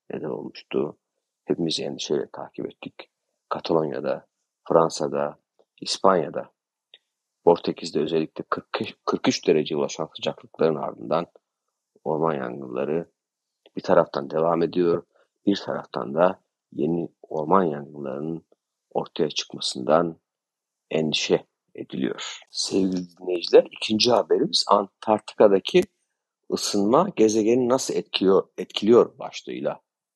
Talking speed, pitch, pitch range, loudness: 85 wpm, 85 Hz, 80-105 Hz, -24 LUFS